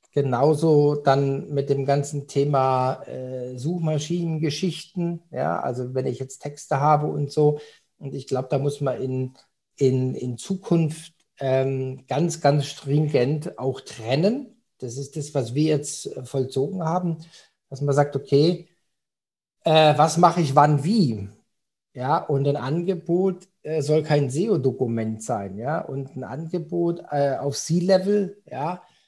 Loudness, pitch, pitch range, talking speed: -23 LUFS, 145 Hz, 135-165 Hz, 140 wpm